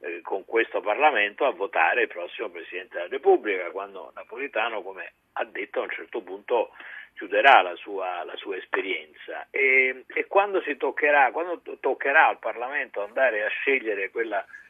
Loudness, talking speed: -24 LUFS, 160 wpm